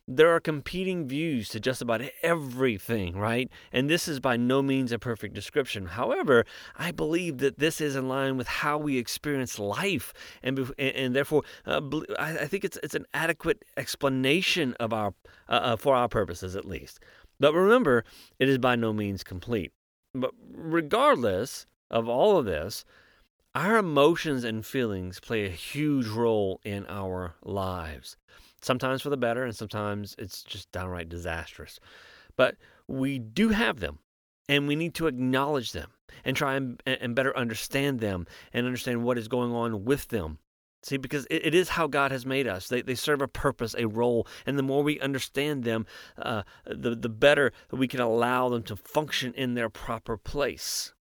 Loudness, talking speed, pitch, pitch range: -28 LUFS, 175 wpm, 125 Hz, 110-140 Hz